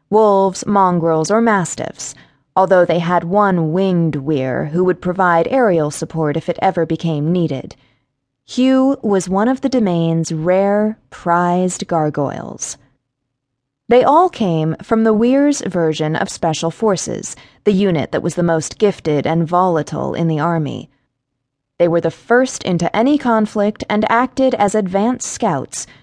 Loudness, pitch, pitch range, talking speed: -16 LUFS, 175 Hz, 155-210 Hz, 145 wpm